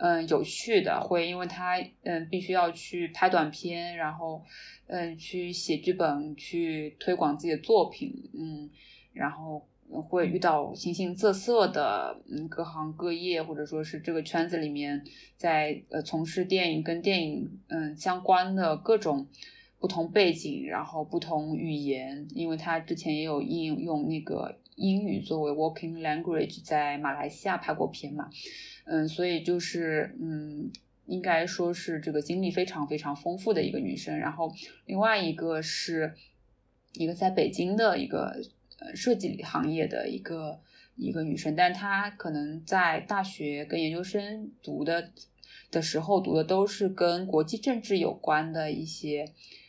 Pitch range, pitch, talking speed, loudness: 155-185 Hz, 165 Hz, 245 characters per minute, -30 LUFS